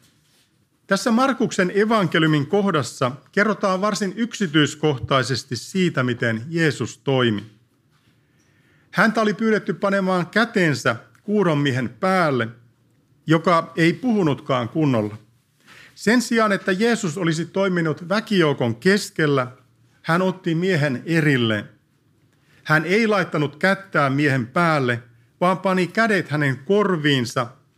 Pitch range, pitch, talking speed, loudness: 135-195 Hz, 155 Hz, 95 wpm, -20 LUFS